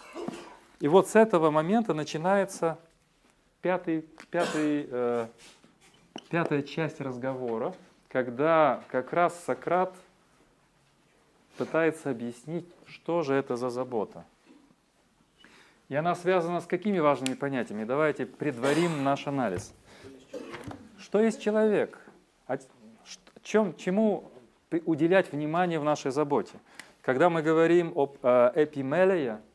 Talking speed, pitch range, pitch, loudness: 95 wpm, 135-180 Hz, 160 Hz, -28 LUFS